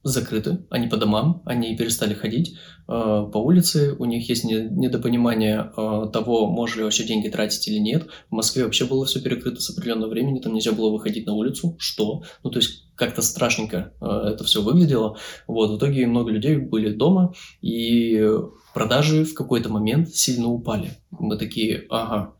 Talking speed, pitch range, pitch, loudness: 175 wpm, 110-140 Hz, 115 Hz, -22 LUFS